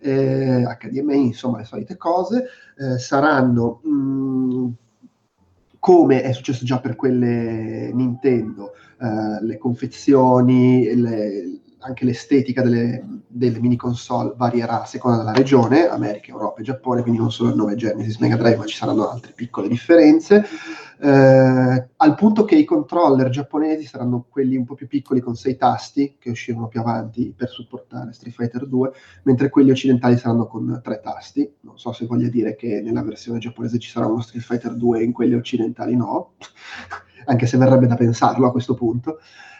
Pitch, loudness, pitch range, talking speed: 125 Hz, -18 LUFS, 120-135 Hz, 165 wpm